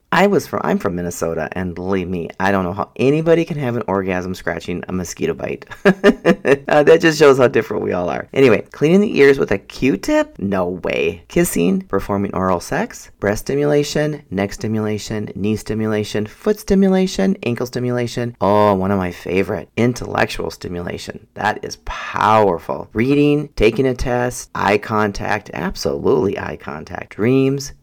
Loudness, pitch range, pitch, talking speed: -18 LUFS, 100-145 Hz, 115 Hz, 155 wpm